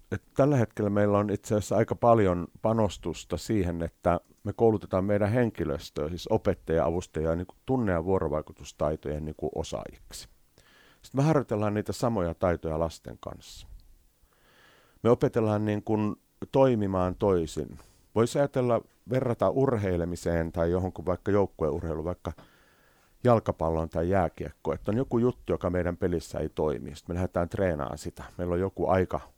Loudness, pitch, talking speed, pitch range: -28 LUFS, 95 Hz, 145 wpm, 85-110 Hz